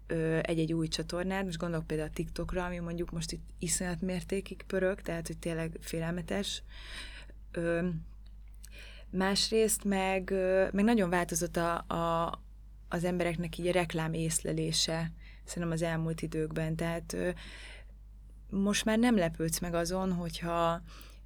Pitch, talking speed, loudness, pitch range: 170 Hz, 125 wpm, -32 LUFS, 165-185 Hz